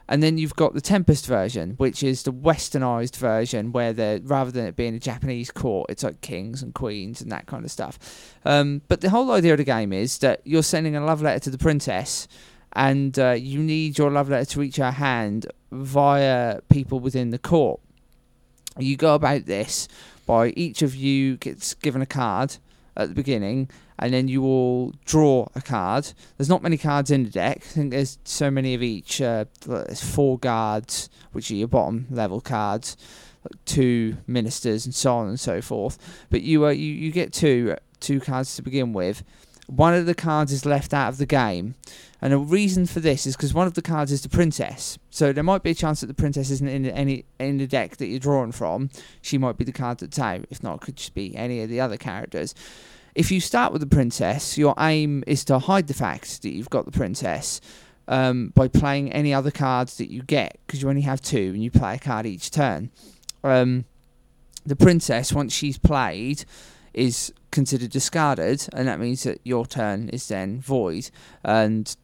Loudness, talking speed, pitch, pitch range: -23 LUFS, 210 wpm, 135 Hz, 120-145 Hz